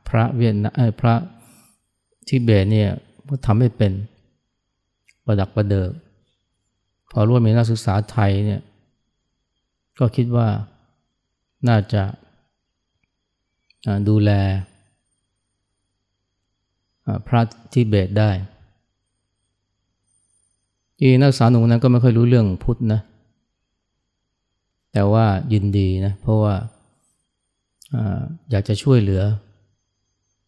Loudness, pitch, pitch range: -19 LUFS, 105 Hz, 100-115 Hz